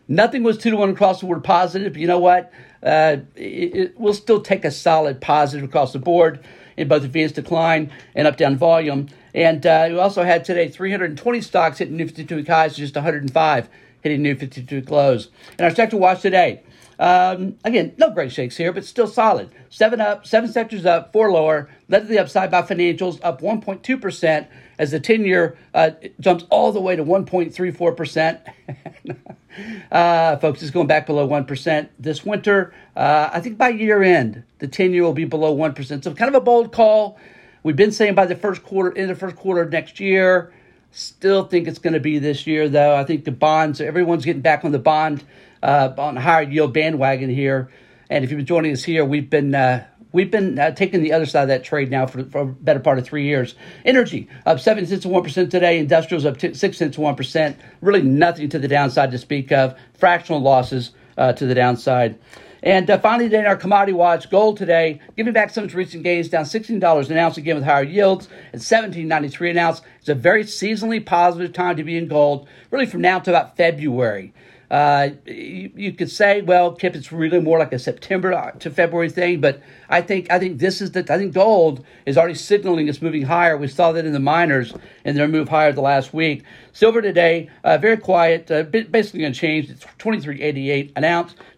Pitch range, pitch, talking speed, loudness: 150-190 Hz, 165 Hz, 215 wpm, -18 LUFS